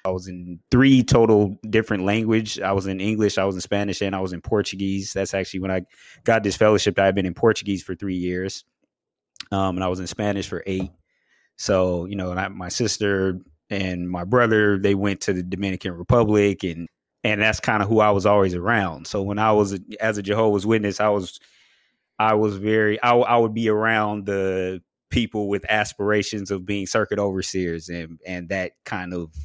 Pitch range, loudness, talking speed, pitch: 95-105 Hz, -22 LUFS, 205 wpm, 100 Hz